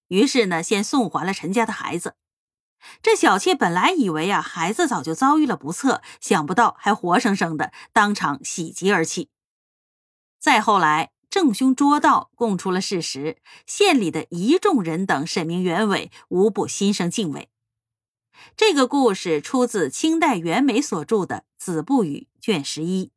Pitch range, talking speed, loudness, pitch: 165-270 Hz, 235 characters per minute, -20 LUFS, 205 Hz